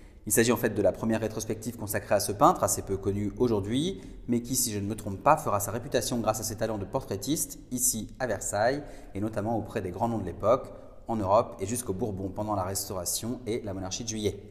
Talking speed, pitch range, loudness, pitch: 235 wpm, 100-120 Hz, -29 LUFS, 110 Hz